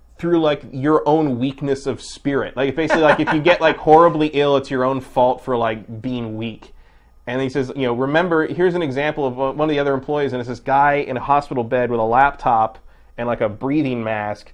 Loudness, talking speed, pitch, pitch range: -18 LUFS, 225 wpm, 135 Hz, 120-150 Hz